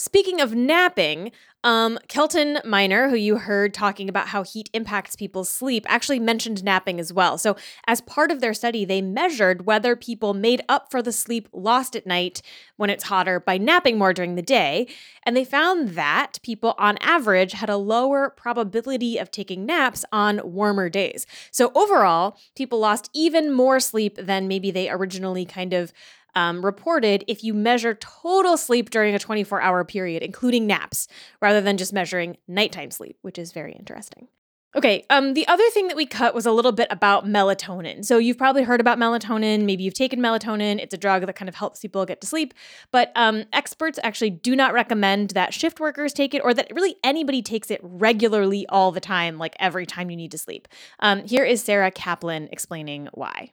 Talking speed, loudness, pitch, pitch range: 195 wpm, -21 LUFS, 215 Hz, 190-245 Hz